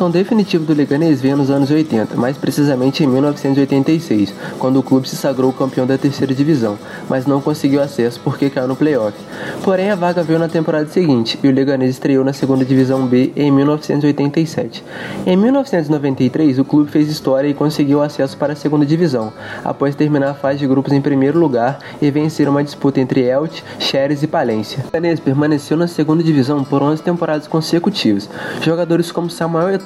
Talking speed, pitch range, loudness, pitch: 180 wpm, 135-160 Hz, -15 LUFS, 145 Hz